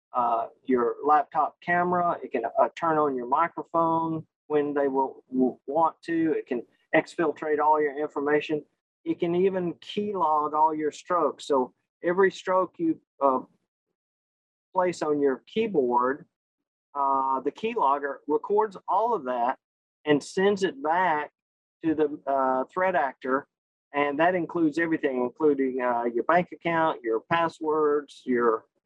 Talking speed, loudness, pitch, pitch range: 140 wpm, -26 LUFS, 155 Hz, 145-175 Hz